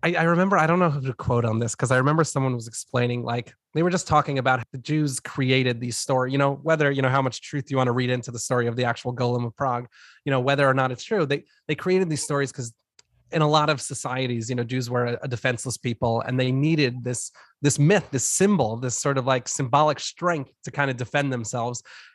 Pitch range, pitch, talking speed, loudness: 125-145 Hz, 130 Hz, 250 wpm, -24 LUFS